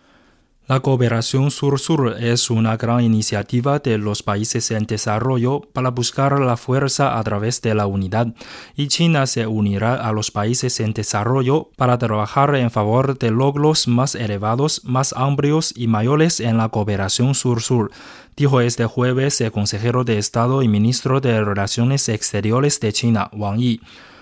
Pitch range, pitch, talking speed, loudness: 110-135 Hz, 120 Hz, 155 wpm, -18 LUFS